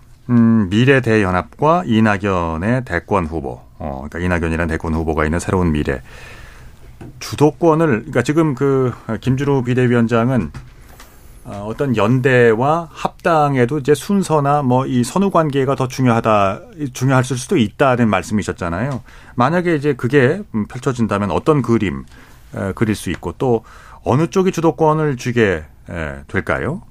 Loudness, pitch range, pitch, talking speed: -17 LUFS, 95-140 Hz, 120 Hz, 295 characters per minute